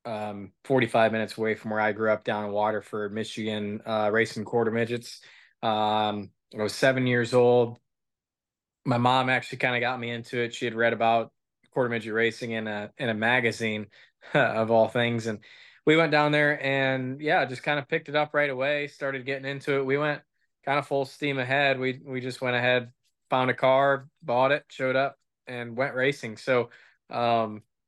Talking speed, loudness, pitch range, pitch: 195 wpm, -26 LUFS, 110-135 Hz, 120 Hz